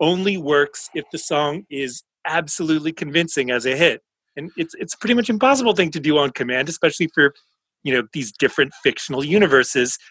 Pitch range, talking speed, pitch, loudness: 140-185 Hz, 180 wpm, 160 Hz, -19 LUFS